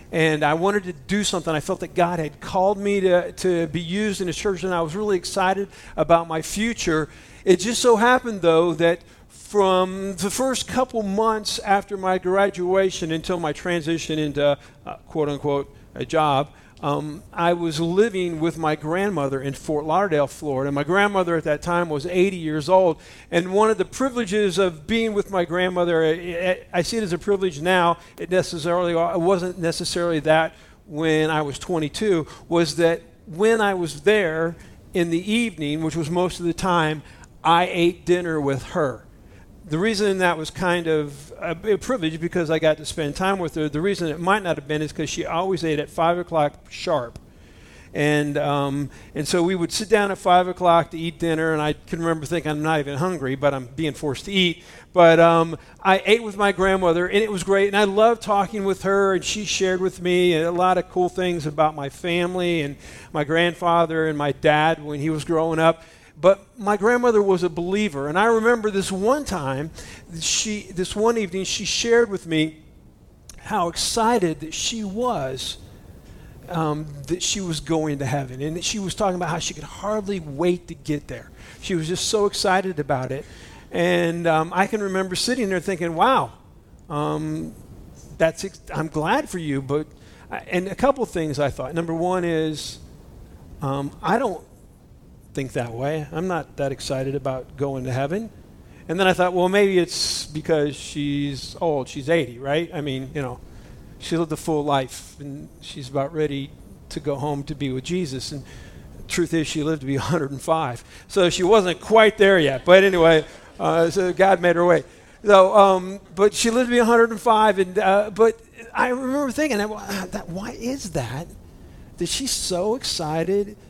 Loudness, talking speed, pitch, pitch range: -21 LUFS, 190 wpm, 170 Hz, 150-195 Hz